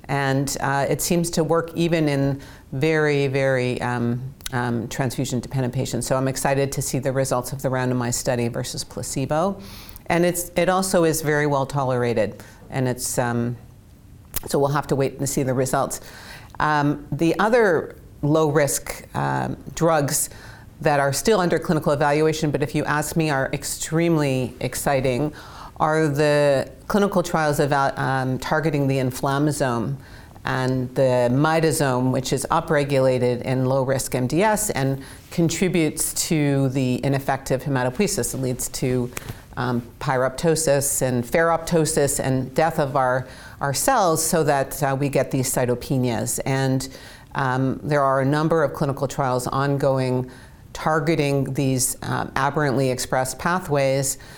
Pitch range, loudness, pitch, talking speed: 130-150 Hz, -22 LUFS, 135 Hz, 140 wpm